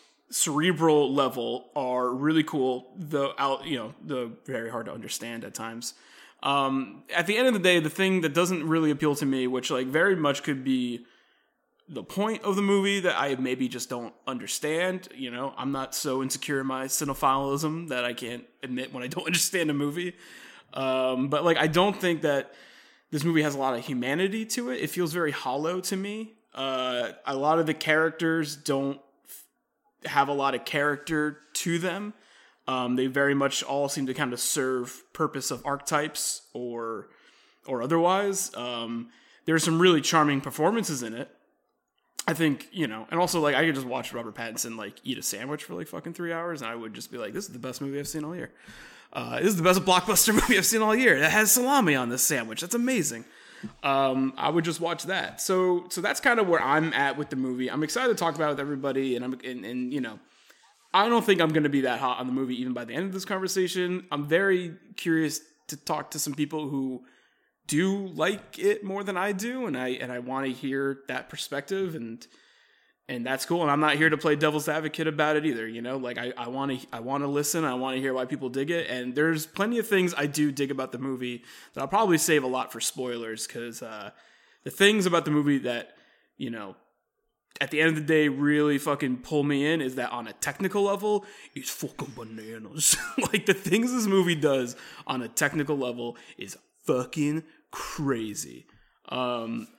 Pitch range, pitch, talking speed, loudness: 130-170 Hz, 150 Hz, 210 wpm, -27 LUFS